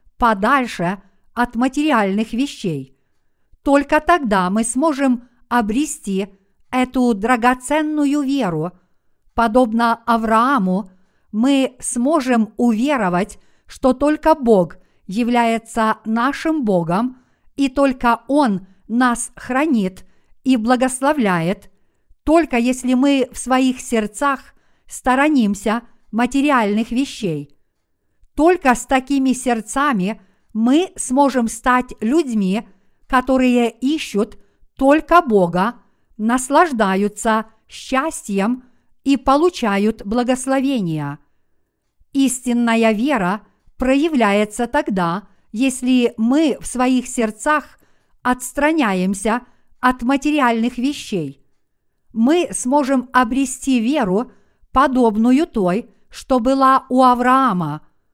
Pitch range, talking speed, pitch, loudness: 210-270 Hz, 80 wpm, 245 Hz, -18 LUFS